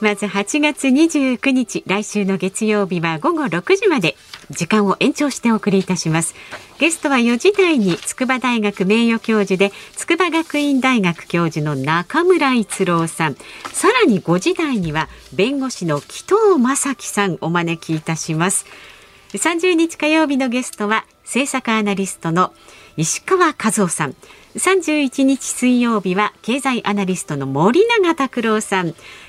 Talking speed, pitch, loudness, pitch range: 265 characters per minute, 215 Hz, -17 LUFS, 185-275 Hz